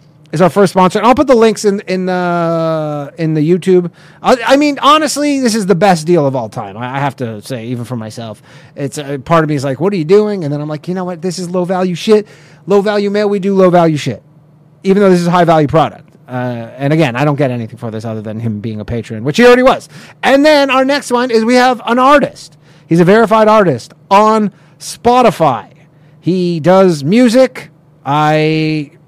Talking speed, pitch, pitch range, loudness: 235 wpm, 170 Hz, 150-205 Hz, -11 LUFS